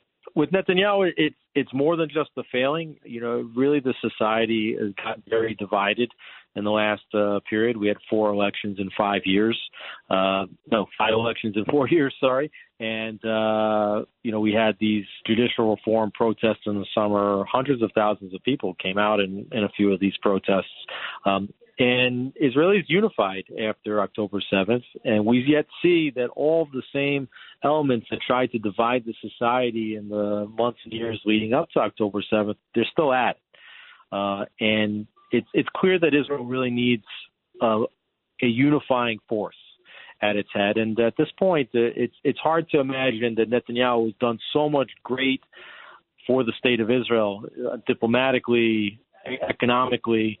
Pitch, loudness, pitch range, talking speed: 115 Hz, -23 LUFS, 105-130 Hz, 170 wpm